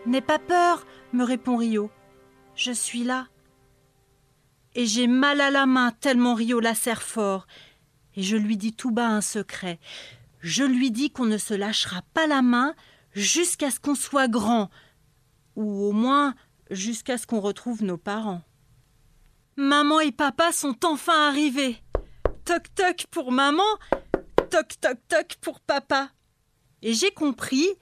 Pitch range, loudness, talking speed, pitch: 180-285 Hz, -24 LUFS, 150 wpm, 240 Hz